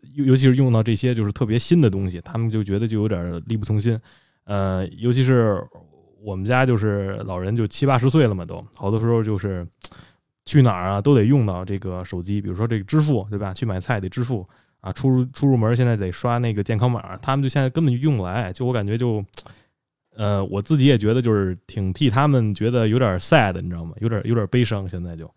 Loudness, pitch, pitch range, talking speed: -21 LUFS, 110 Hz, 100-125 Hz, 345 characters per minute